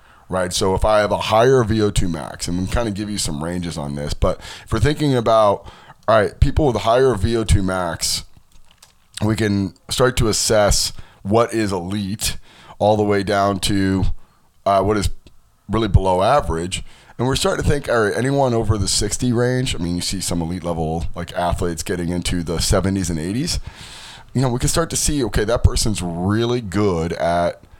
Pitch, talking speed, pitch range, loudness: 100 Hz, 195 wpm, 90-110 Hz, -19 LUFS